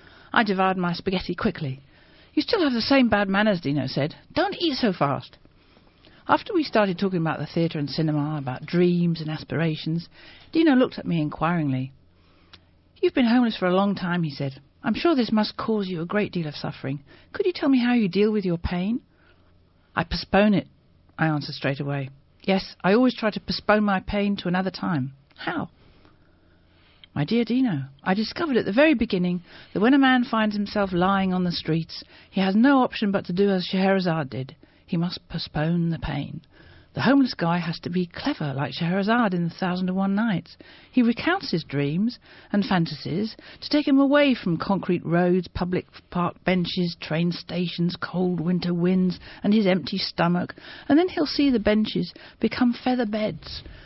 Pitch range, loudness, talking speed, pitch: 160-215 Hz, -24 LUFS, 185 wpm, 180 Hz